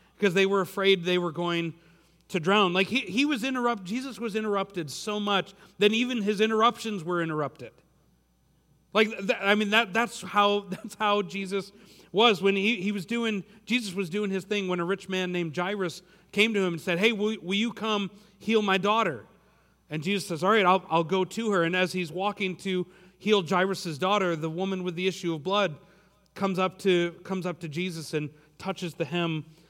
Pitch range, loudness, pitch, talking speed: 180-210 Hz, -27 LUFS, 195 Hz, 205 wpm